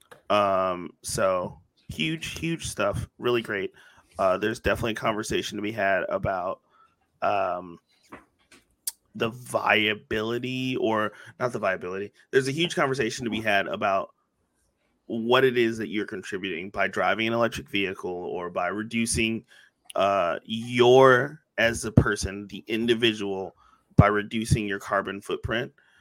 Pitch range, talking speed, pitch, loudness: 100-125 Hz, 130 wpm, 115 Hz, -26 LUFS